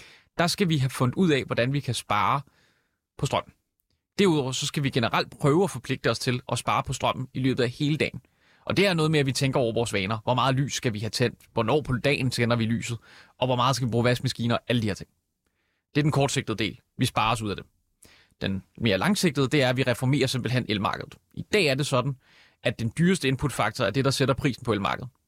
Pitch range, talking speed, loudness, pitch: 115-140 Hz, 245 wpm, -25 LUFS, 125 Hz